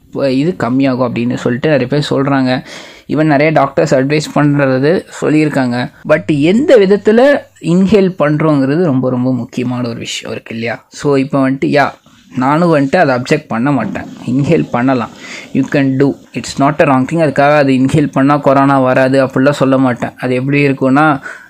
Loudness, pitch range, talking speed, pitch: -12 LUFS, 130-155 Hz, 160 wpm, 140 Hz